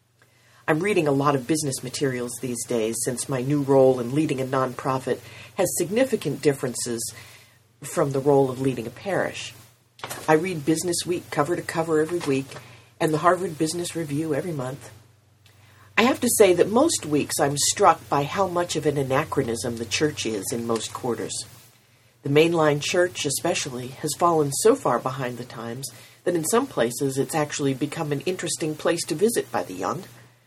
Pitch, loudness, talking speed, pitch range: 140 Hz, -24 LUFS, 175 wpm, 120-160 Hz